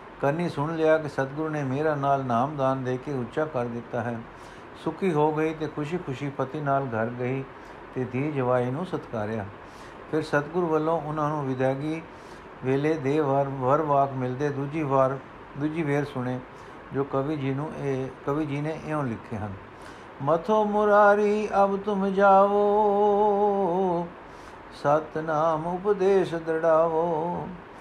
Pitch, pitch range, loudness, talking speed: 150 Hz, 135-165 Hz, -26 LUFS, 140 wpm